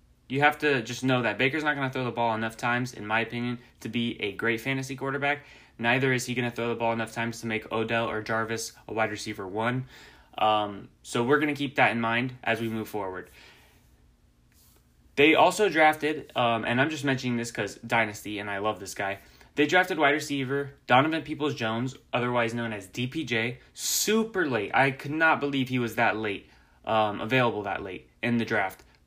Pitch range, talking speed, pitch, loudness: 110-135 Hz, 205 wpm, 120 Hz, -27 LUFS